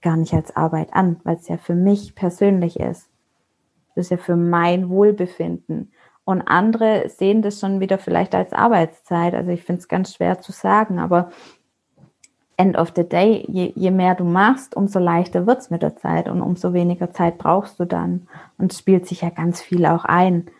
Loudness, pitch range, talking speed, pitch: -19 LUFS, 170-195 Hz, 195 wpm, 180 Hz